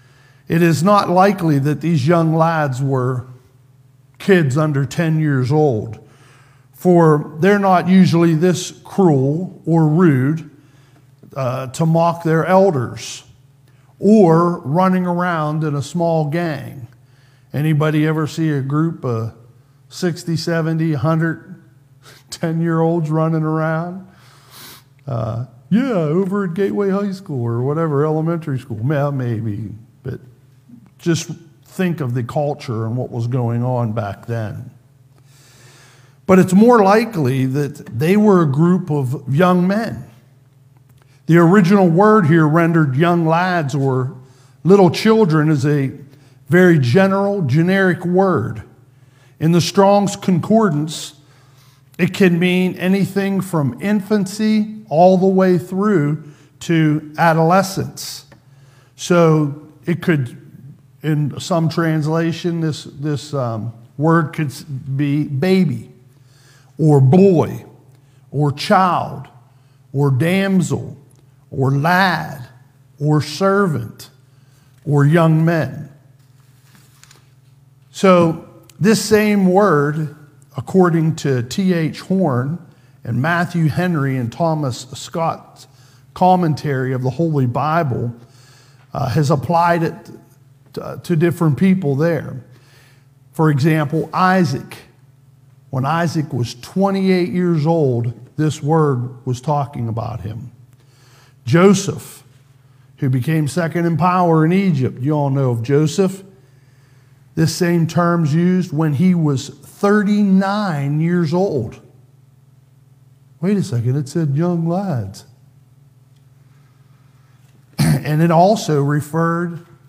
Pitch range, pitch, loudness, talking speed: 130-170 Hz, 150 Hz, -16 LUFS, 110 wpm